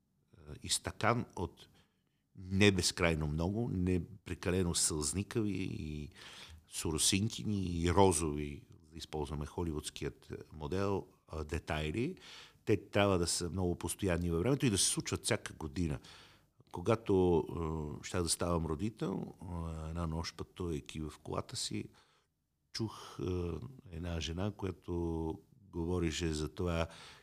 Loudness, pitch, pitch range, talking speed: -36 LUFS, 85 Hz, 80-100 Hz, 105 wpm